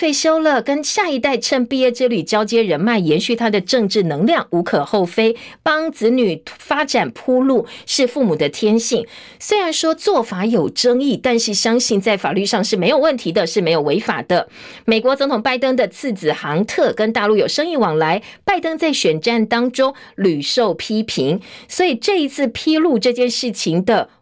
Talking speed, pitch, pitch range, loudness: 275 characters per minute, 240 Hz, 210-270 Hz, -17 LUFS